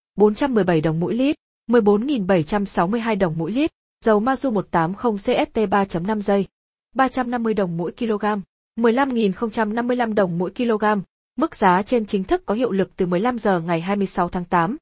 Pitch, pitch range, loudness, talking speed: 210 Hz, 185-240 Hz, -21 LUFS, 145 wpm